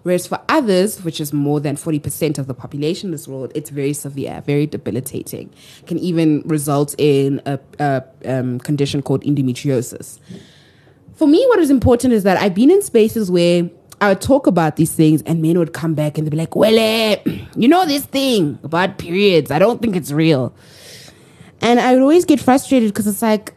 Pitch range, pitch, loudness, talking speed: 145-215 Hz, 165 Hz, -16 LUFS, 200 wpm